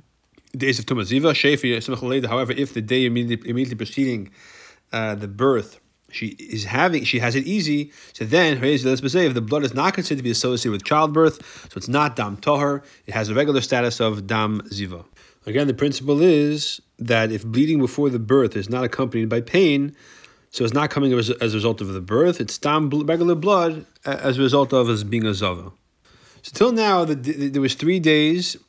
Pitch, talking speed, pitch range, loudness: 130 Hz, 190 wpm, 115-145 Hz, -20 LUFS